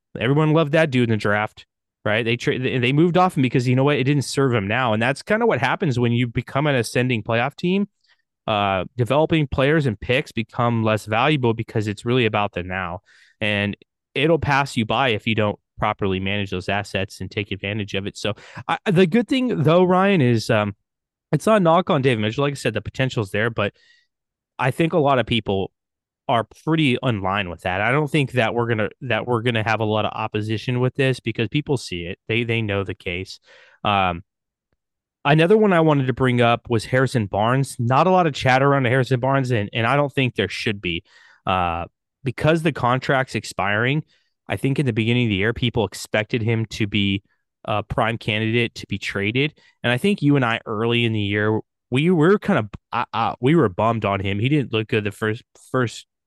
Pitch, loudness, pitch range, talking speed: 120 Hz, -21 LUFS, 105-140 Hz, 220 wpm